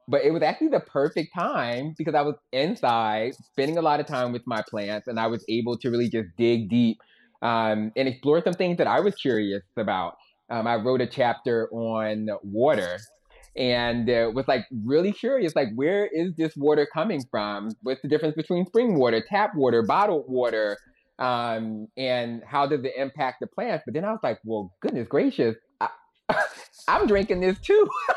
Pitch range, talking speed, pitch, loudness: 115-160 Hz, 190 wpm, 130 Hz, -25 LUFS